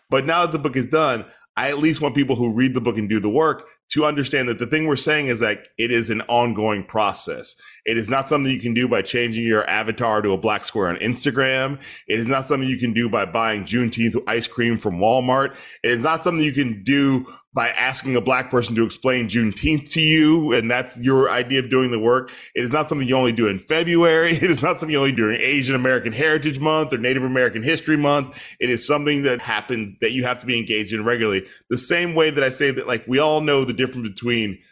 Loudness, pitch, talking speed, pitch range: -20 LUFS, 130 Hz, 250 wpm, 115-145 Hz